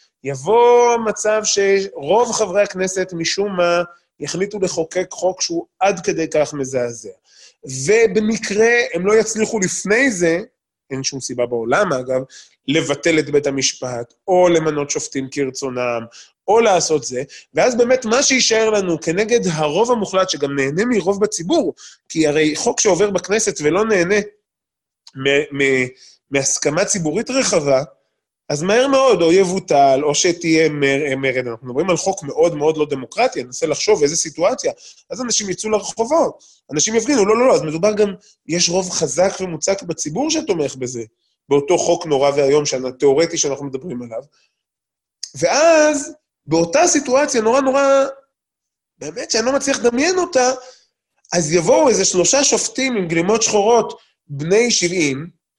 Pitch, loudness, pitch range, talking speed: 180 Hz, -17 LUFS, 145-220 Hz, 140 wpm